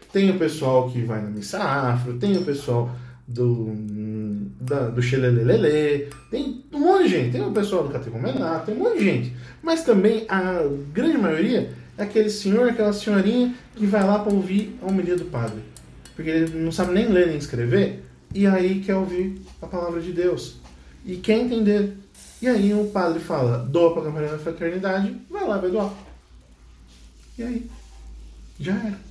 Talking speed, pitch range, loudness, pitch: 175 wpm, 120-205 Hz, -22 LUFS, 170 Hz